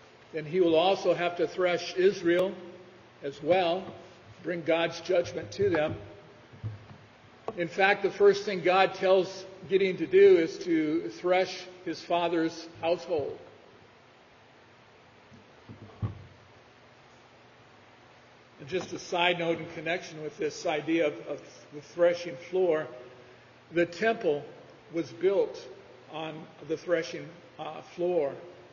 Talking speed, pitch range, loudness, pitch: 115 wpm, 155-185 Hz, -28 LUFS, 175 Hz